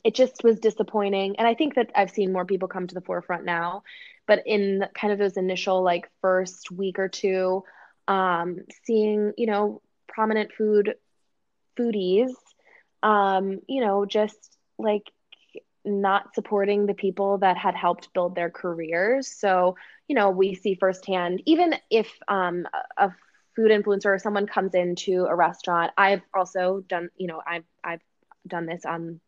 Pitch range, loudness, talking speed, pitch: 185-215 Hz, -24 LUFS, 160 wpm, 195 Hz